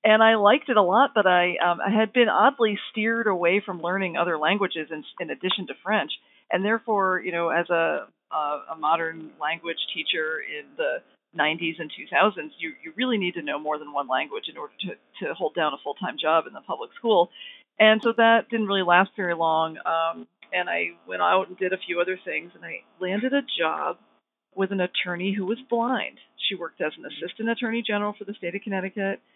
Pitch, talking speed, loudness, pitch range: 190 Hz, 220 wpm, -24 LUFS, 170-225 Hz